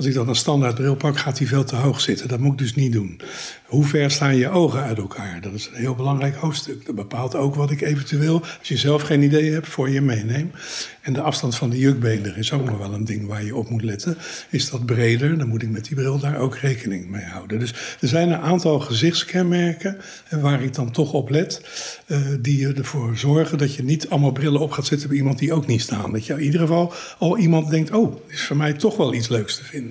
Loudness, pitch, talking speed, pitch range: -21 LUFS, 140 Hz, 255 wpm, 125-155 Hz